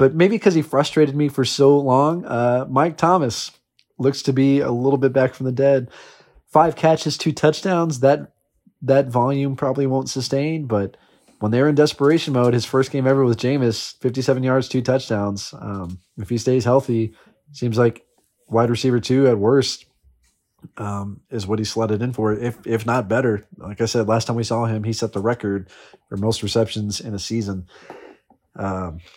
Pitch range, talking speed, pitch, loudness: 110-140 Hz, 185 wpm, 125 Hz, -20 LUFS